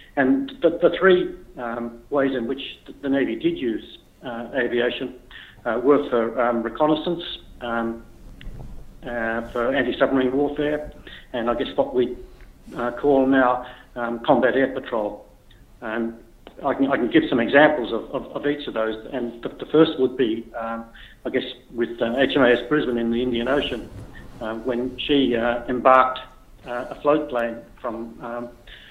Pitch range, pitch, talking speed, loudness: 115-140 Hz, 125 Hz, 165 wpm, -22 LUFS